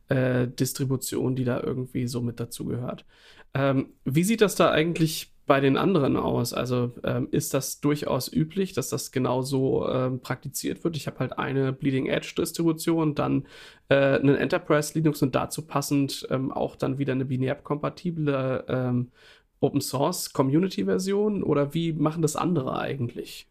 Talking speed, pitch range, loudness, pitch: 160 wpm, 130-155 Hz, -26 LUFS, 140 Hz